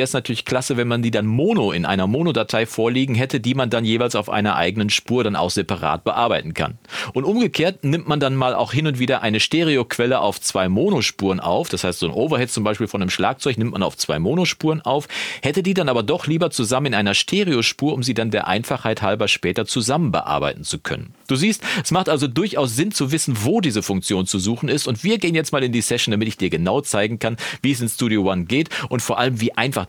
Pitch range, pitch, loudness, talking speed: 110-145 Hz, 125 Hz, -20 LUFS, 240 wpm